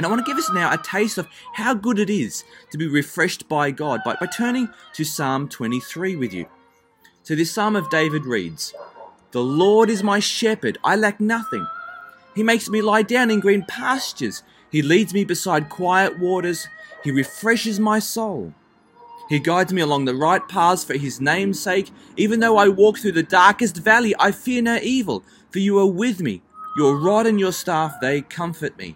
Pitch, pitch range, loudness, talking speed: 195 Hz, 155-220 Hz, -20 LUFS, 195 wpm